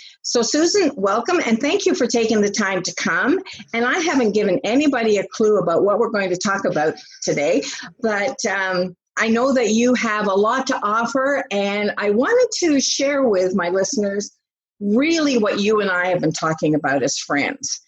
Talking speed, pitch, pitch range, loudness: 190 wpm, 220 Hz, 195-265 Hz, -19 LUFS